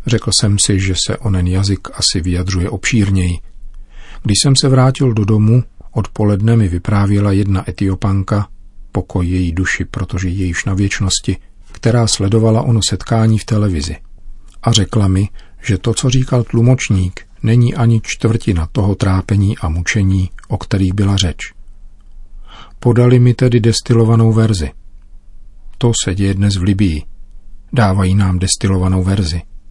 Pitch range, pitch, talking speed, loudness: 95-110 Hz, 100 Hz, 140 wpm, -14 LUFS